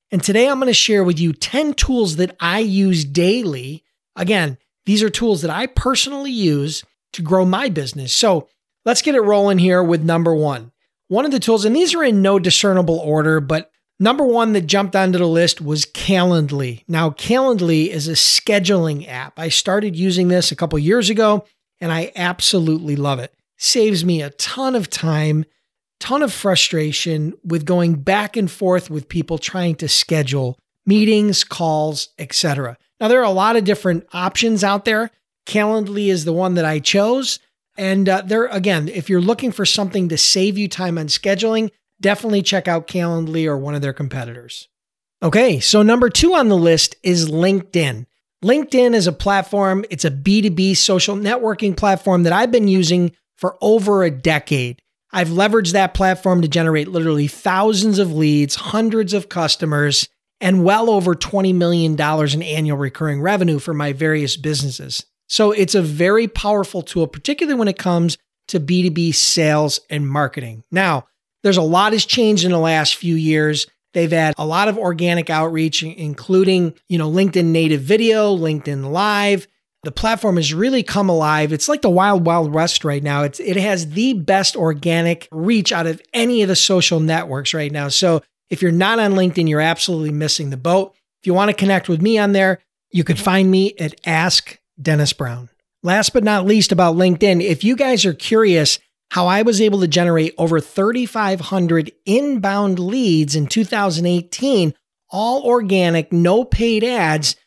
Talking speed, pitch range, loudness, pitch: 180 wpm, 160-205 Hz, -16 LUFS, 180 Hz